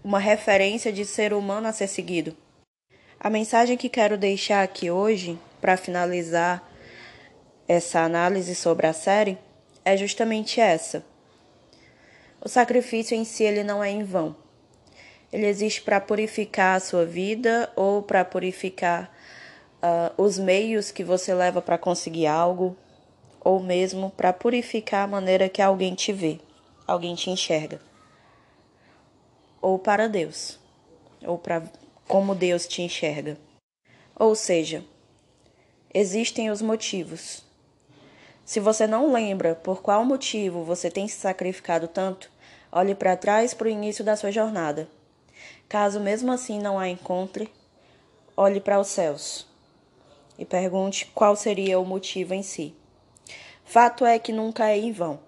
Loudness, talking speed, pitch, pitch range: -24 LUFS, 135 wpm, 195 Hz, 180-215 Hz